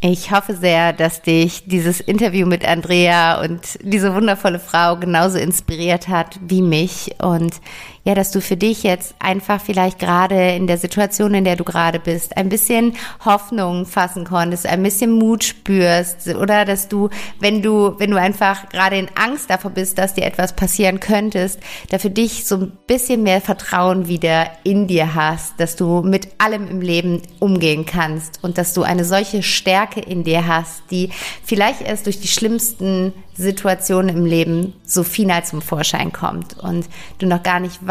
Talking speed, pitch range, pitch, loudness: 175 wpm, 175-200 Hz, 185 Hz, -17 LUFS